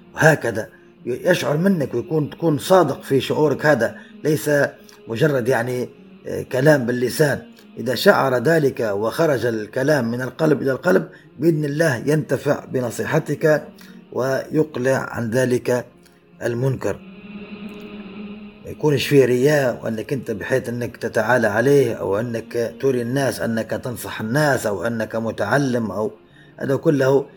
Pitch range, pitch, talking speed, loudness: 120-155 Hz, 135 Hz, 115 wpm, -20 LUFS